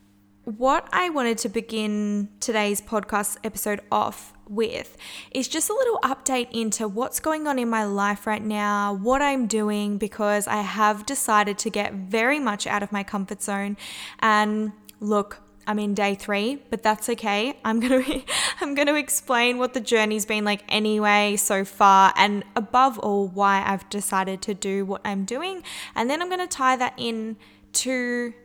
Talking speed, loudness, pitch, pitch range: 170 wpm, -23 LUFS, 215 Hz, 205-250 Hz